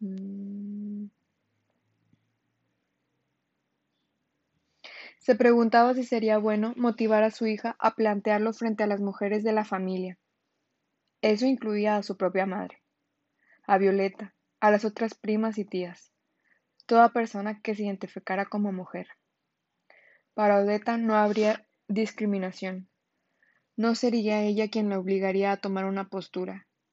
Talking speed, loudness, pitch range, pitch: 120 wpm, -27 LUFS, 195-220 Hz, 210 Hz